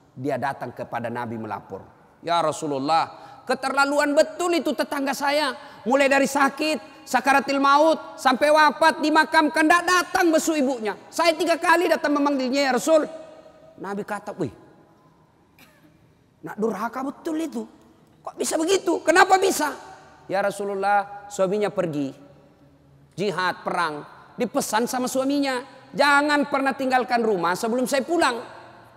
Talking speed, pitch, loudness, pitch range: 125 wpm, 270 Hz, -22 LUFS, 190-305 Hz